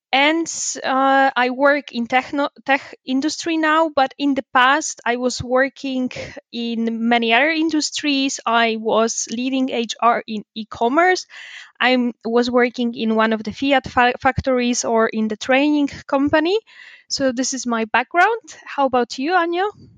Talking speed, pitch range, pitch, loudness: 150 wpm, 235-285 Hz, 260 Hz, -18 LUFS